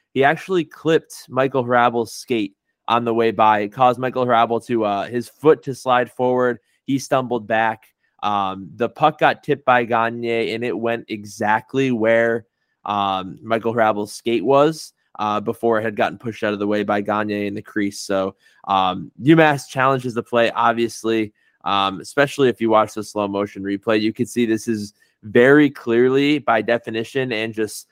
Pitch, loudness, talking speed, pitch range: 115 Hz, -19 LUFS, 180 wpm, 105-125 Hz